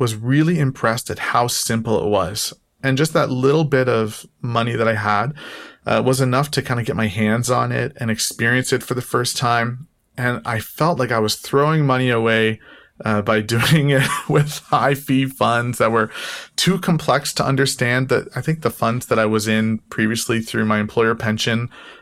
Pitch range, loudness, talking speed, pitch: 110-135 Hz, -19 LUFS, 200 wpm, 120 Hz